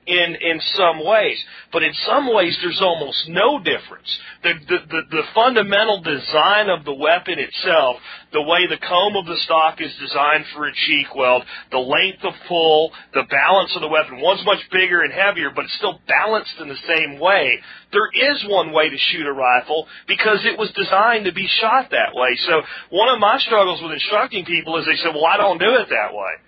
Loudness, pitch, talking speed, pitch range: -17 LUFS, 170 Hz, 210 wpm, 155-195 Hz